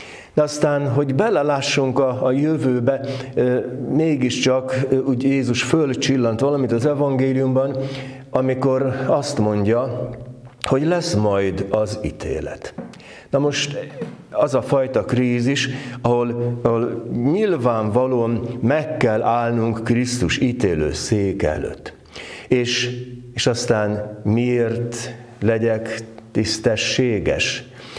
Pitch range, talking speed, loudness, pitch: 115-135 Hz, 95 wpm, -20 LUFS, 125 Hz